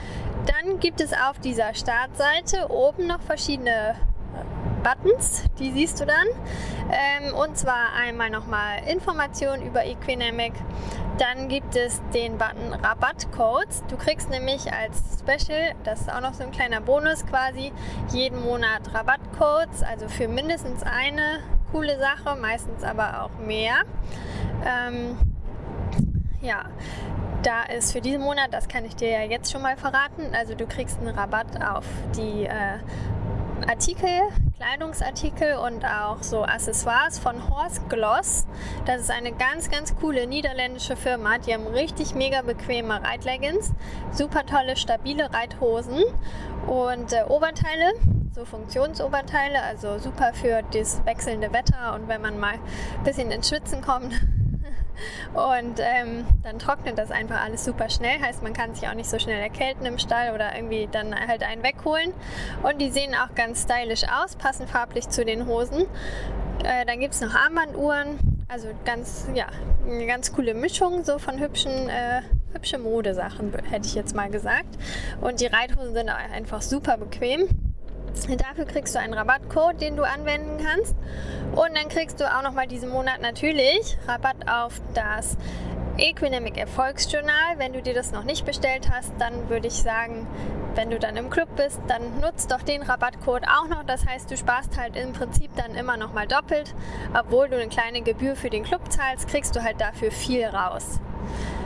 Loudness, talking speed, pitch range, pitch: -25 LUFS, 160 wpm, 235-295 Hz, 260 Hz